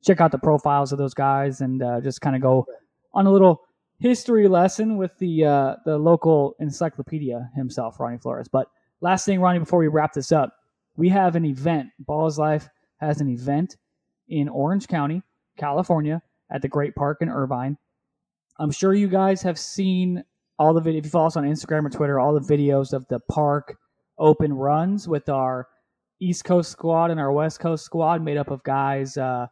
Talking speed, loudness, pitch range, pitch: 195 wpm, -22 LUFS, 140-170 Hz, 150 Hz